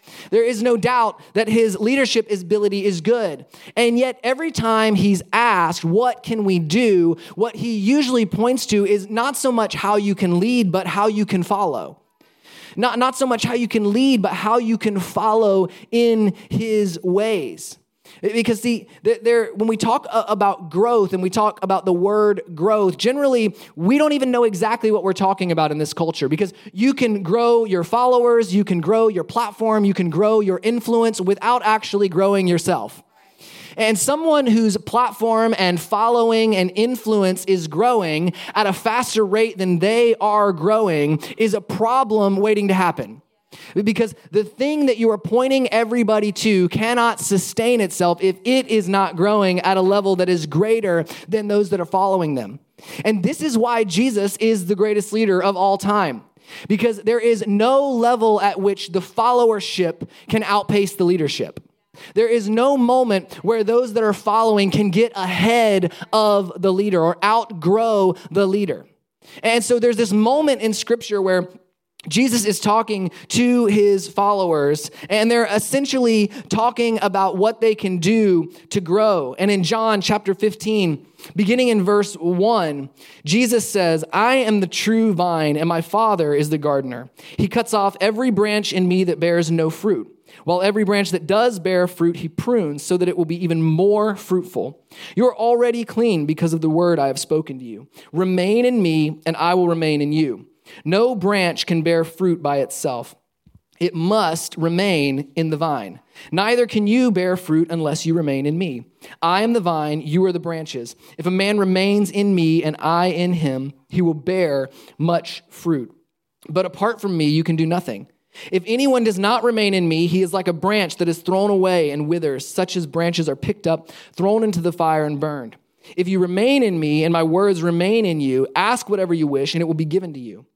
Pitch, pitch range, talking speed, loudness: 200 Hz, 175-225 Hz, 185 wpm, -18 LUFS